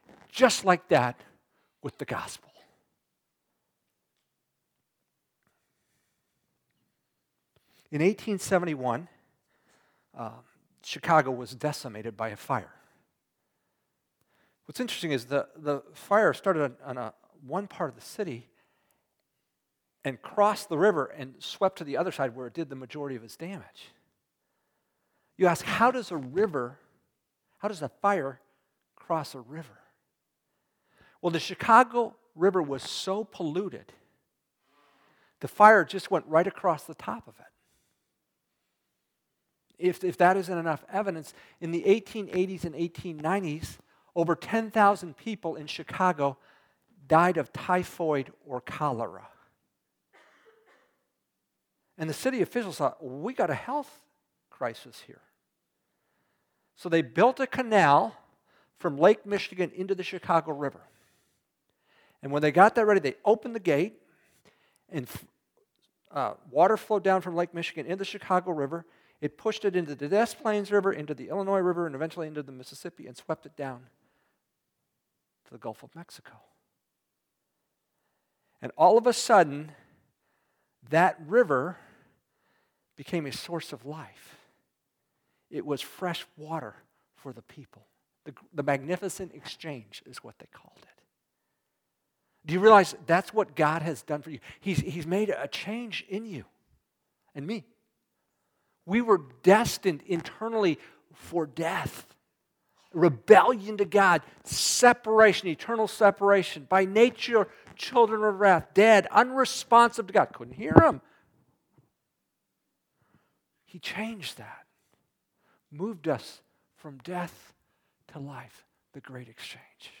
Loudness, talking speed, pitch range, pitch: -26 LUFS, 125 wpm, 150-205 Hz, 175 Hz